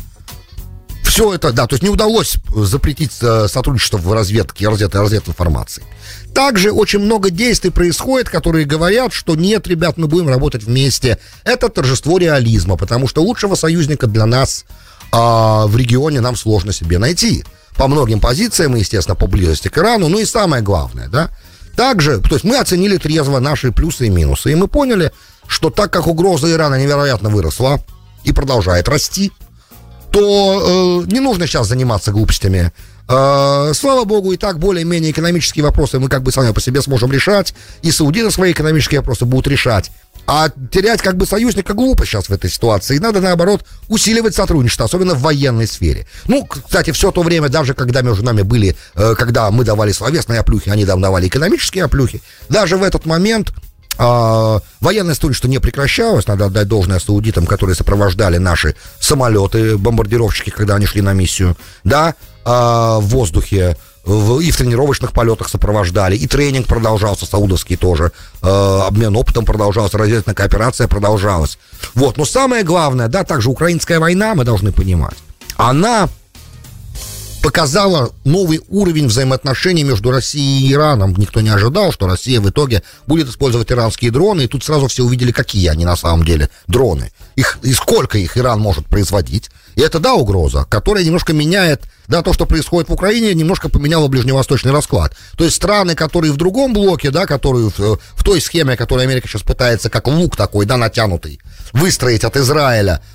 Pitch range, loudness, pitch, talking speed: 105-160 Hz, -13 LUFS, 125 Hz, 165 wpm